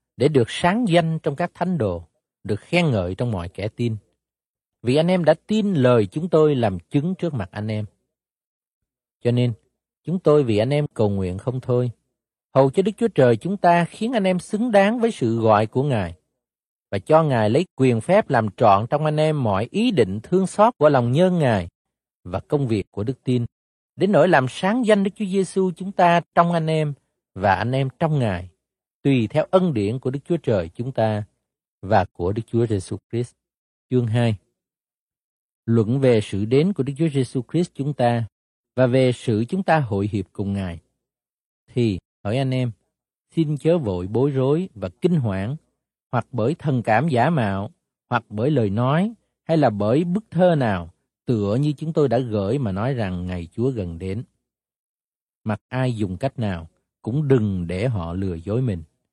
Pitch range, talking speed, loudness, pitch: 105-155 Hz, 195 wpm, -21 LUFS, 125 Hz